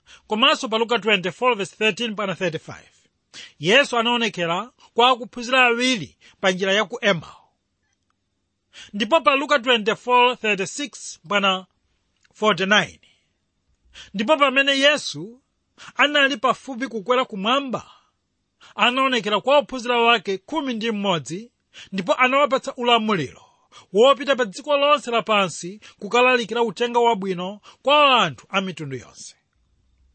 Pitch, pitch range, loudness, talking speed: 225 Hz, 185-255 Hz, -20 LUFS, 90 wpm